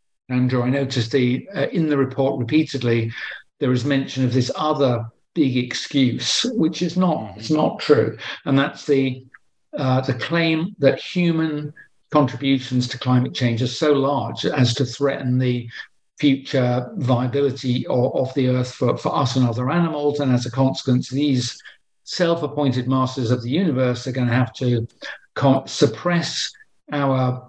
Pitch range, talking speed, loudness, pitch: 125-145 Hz, 155 wpm, -21 LUFS, 135 Hz